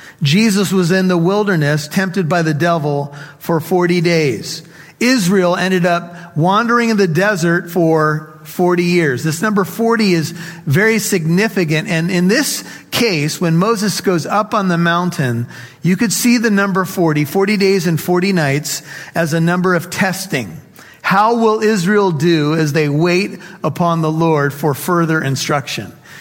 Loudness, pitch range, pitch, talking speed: -15 LUFS, 160-195 Hz, 175 Hz, 155 wpm